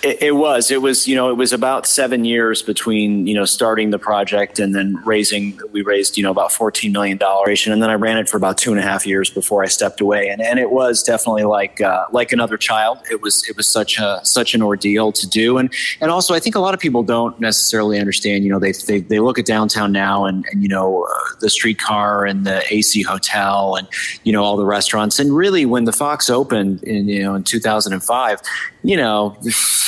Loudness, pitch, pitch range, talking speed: -15 LUFS, 105 Hz, 100-115 Hz, 240 wpm